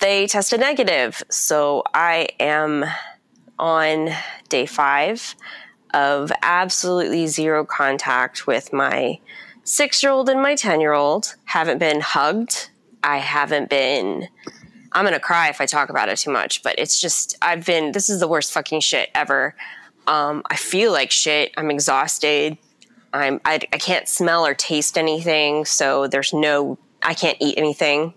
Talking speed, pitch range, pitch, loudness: 145 wpm, 150-180 Hz, 155 Hz, -19 LUFS